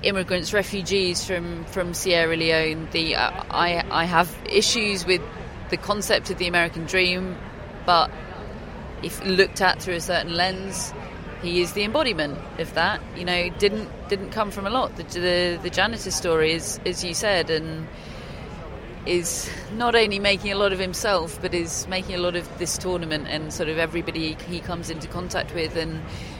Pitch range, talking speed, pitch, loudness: 170-195 Hz, 175 wpm, 180 Hz, -23 LUFS